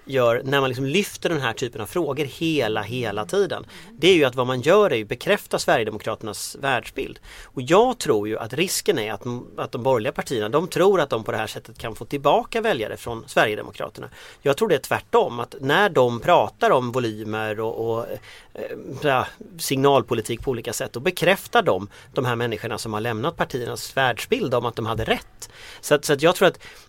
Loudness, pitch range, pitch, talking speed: -22 LUFS, 115-165 Hz, 130 Hz, 205 wpm